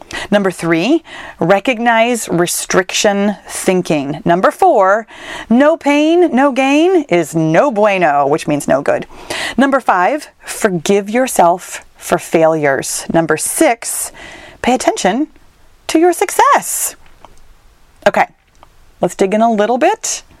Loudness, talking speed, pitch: -13 LUFS, 110 wpm, 230 Hz